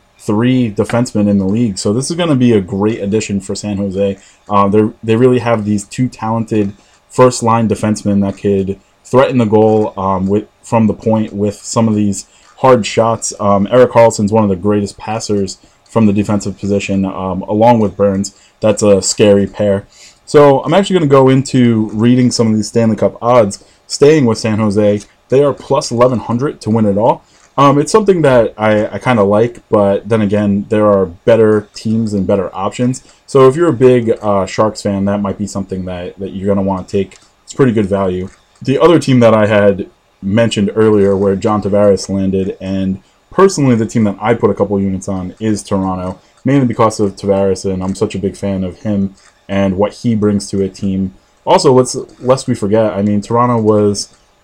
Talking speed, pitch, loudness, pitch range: 200 wpm, 105 Hz, -13 LUFS, 100-115 Hz